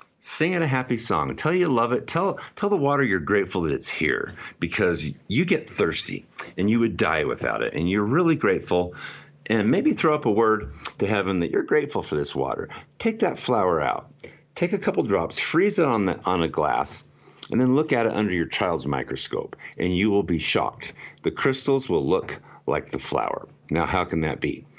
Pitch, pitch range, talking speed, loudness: 110 Hz, 90-140 Hz, 210 wpm, -24 LUFS